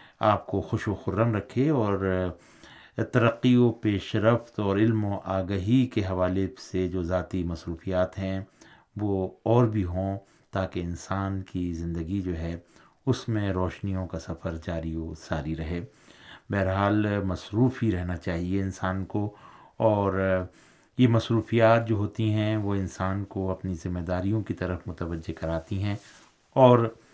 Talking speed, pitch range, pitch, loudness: 145 wpm, 90-110 Hz, 95 Hz, -27 LUFS